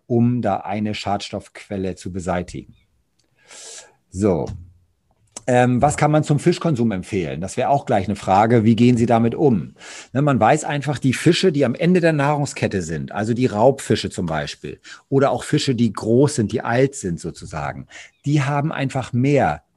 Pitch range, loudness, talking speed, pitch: 100-140 Hz, -19 LUFS, 170 wpm, 120 Hz